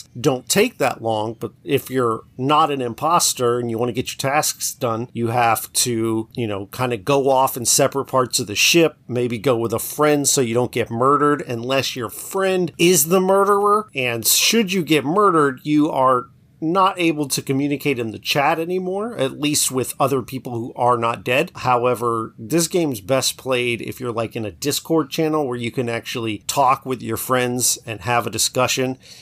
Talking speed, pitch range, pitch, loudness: 200 wpm, 120-150 Hz, 130 Hz, -19 LUFS